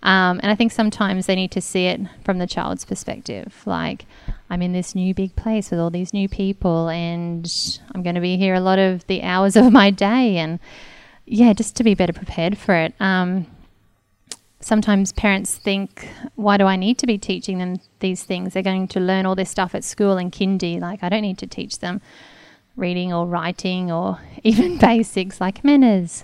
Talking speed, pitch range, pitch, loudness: 205 wpm, 180-205 Hz, 190 Hz, -19 LUFS